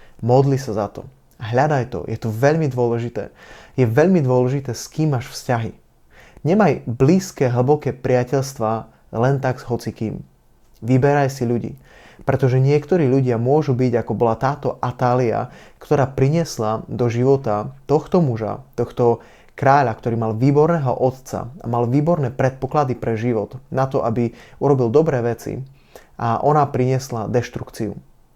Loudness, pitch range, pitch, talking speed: -19 LUFS, 120-140 Hz, 130 Hz, 140 wpm